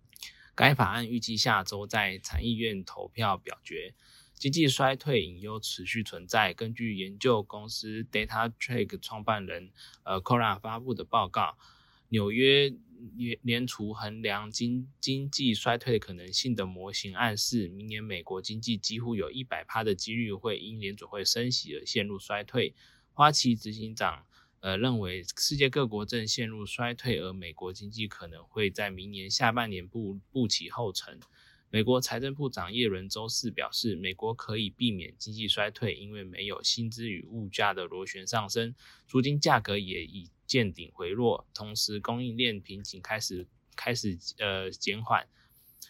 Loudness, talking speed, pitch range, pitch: -30 LUFS, 255 characters per minute, 100-120 Hz, 110 Hz